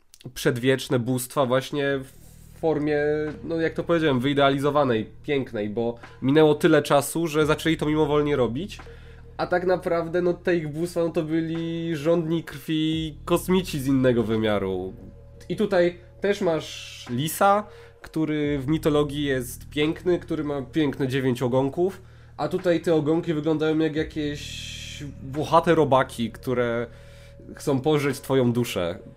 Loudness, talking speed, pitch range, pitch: -24 LUFS, 130 wpm, 130-165 Hz, 150 Hz